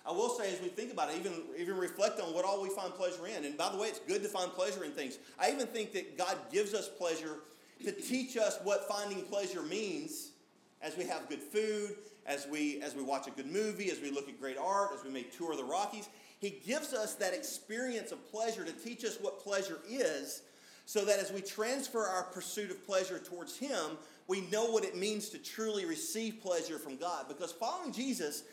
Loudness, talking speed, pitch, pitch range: -38 LUFS, 225 wpm, 205 Hz, 180-245 Hz